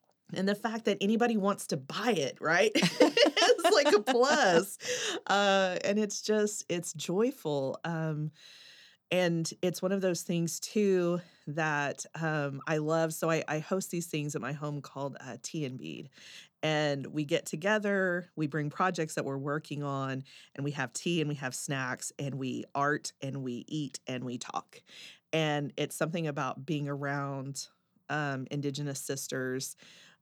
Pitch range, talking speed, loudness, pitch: 140-185 Hz, 165 wpm, -31 LUFS, 155 Hz